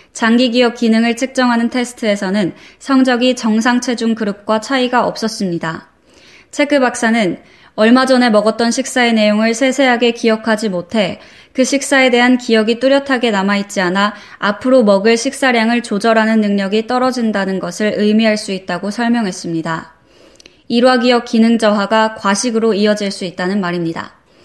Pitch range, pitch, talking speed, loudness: 205-245 Hz, 225 Hz, 350 characters per minute, -14 LUFS